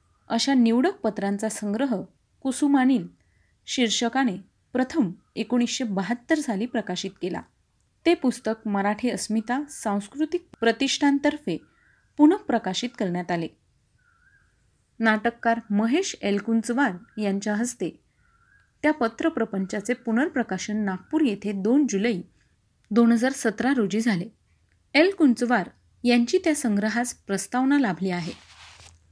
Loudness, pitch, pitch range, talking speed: -24 LUFS, 235 Hz, 205-270 Hz, 95 wpm